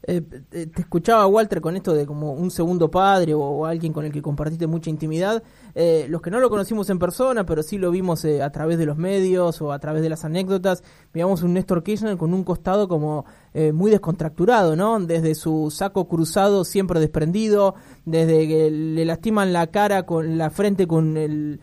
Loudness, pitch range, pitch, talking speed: -21 LUFS, 155-195 Hz, 170 Hz, 205 wpm